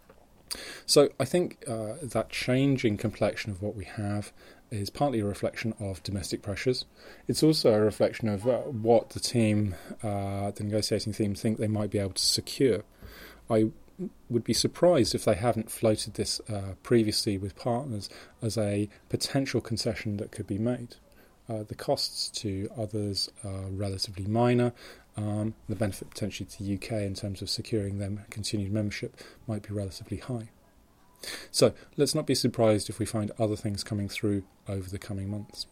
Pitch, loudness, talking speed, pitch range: 110 Hz, -29 LUFS, 170 wpm, 100-115 Hz